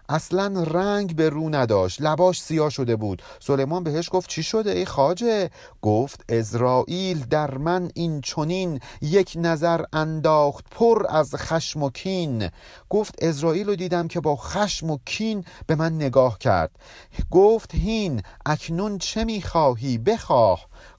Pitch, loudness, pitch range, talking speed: 160 Hz, -23 LUFS, 140-185 Hz, 140 wpm